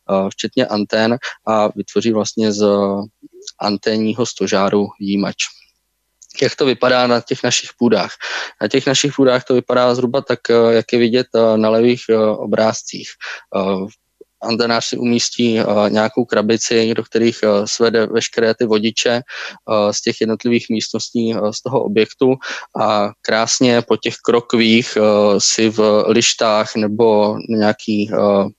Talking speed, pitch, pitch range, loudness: 125 wpm, 110 Hz, 105-120 Hz, -16 LUFS